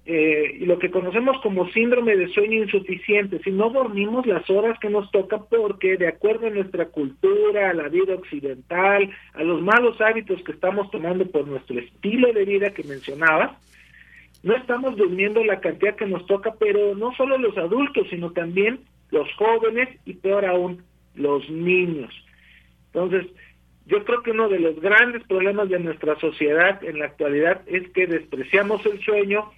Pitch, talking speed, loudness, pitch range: 195 Hz, 170 wpm, -21 LUFS, 170-215 Hz